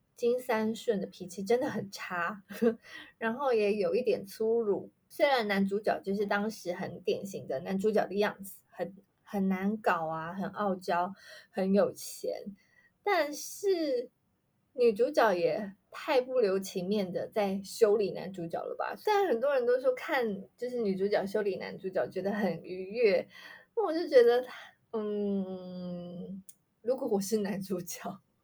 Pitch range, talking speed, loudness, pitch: 190-295 Hz, 220 characters per minute, -31 LUFS, 210 Hz